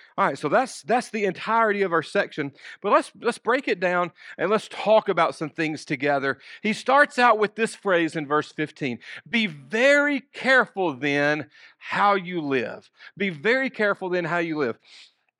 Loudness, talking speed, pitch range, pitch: -23 LUFS, 180 wpm, 155-225 Hz, 195 Hz